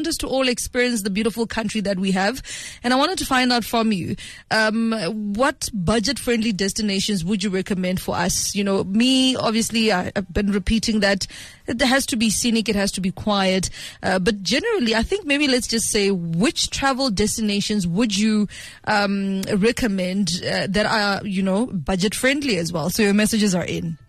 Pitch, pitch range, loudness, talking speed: 215 Hz, 195-235 Hz, -20 LUFS, 190 wpm